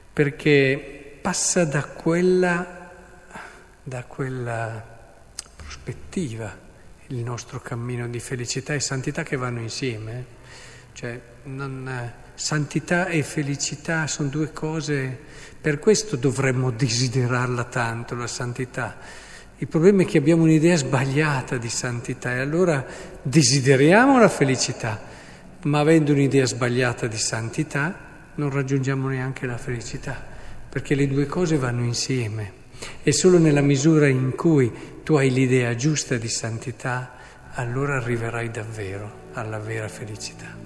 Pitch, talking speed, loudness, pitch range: 135 Hz, 120 wpm, -22 LUFS, 120-150 Hz